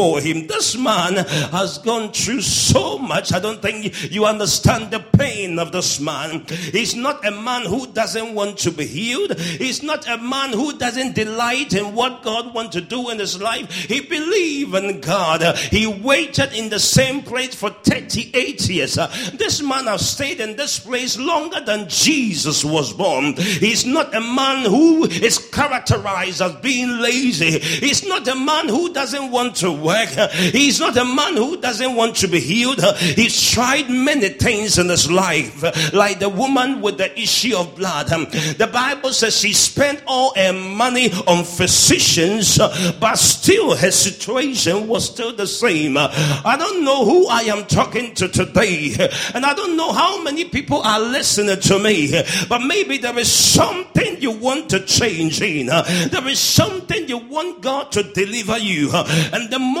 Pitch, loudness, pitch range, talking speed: 220 Hz, -17 LUFS, 185-260 Hz, 175 wpm